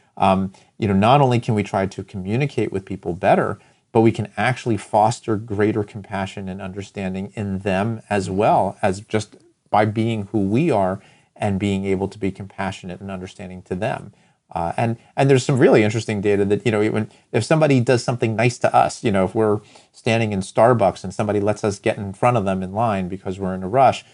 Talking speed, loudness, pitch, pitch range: 210 wpm, -20 LUFS, 105 Hz, 95-115 Hz